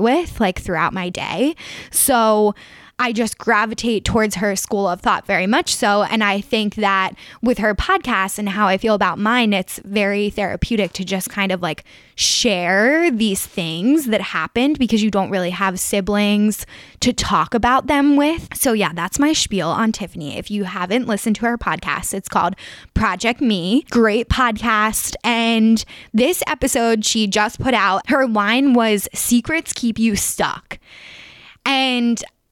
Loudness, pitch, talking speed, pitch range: -18 LUFS, 220 Hz, 165 wpm, 200-245 Hz